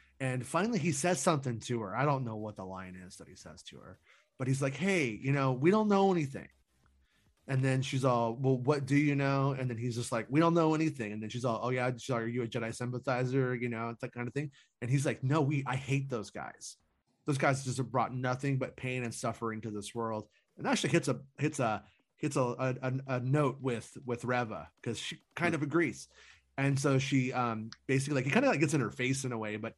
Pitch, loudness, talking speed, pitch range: 130 Hz, -33 LUFS, 250 wpm, 120-140 Hz